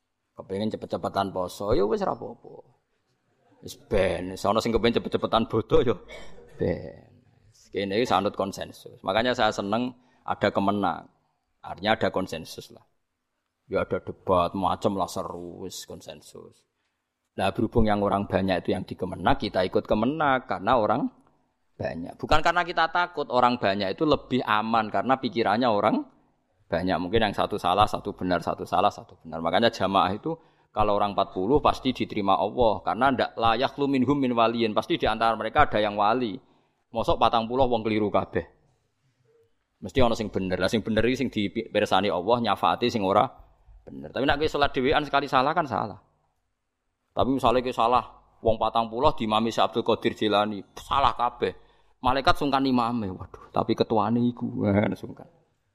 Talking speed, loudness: 160 wpm, -25 LUFS